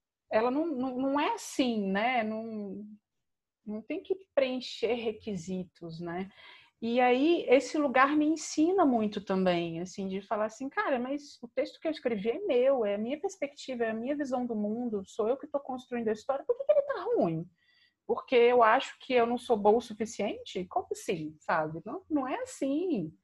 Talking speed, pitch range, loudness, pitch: 195 wpm, 210-295 Hz, -30 LUFS, 250 Hz